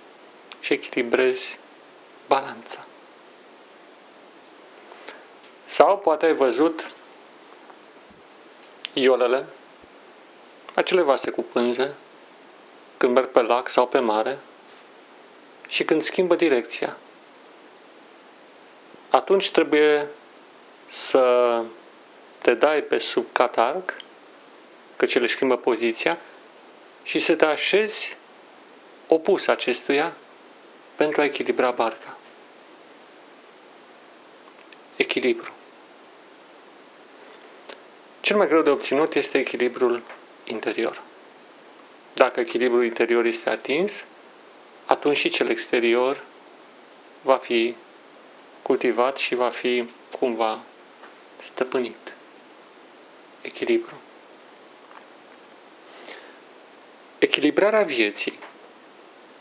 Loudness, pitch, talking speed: -22 LUFS, 160 Hz, 75 wpm